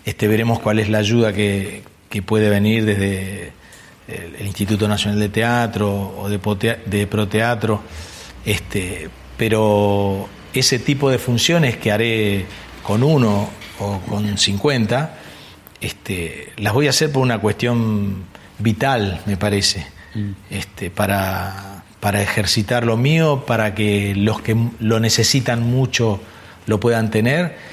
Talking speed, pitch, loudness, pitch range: 130 wpm, 105 Hz, -18 LUFS, 100-115 Hz